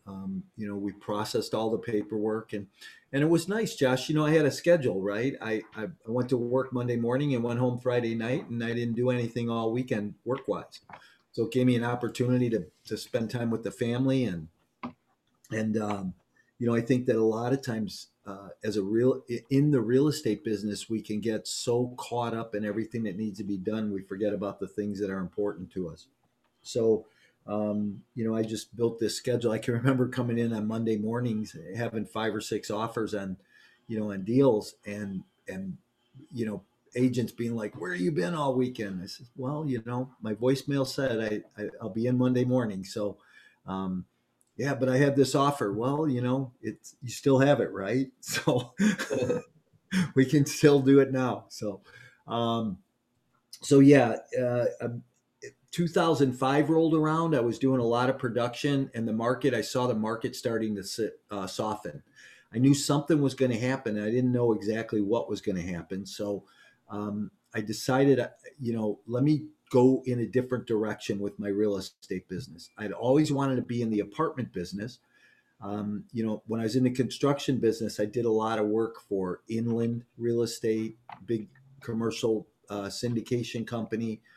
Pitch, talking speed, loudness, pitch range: 115 Hz, 195 wpm, -29 LUFS, 105-130 Hz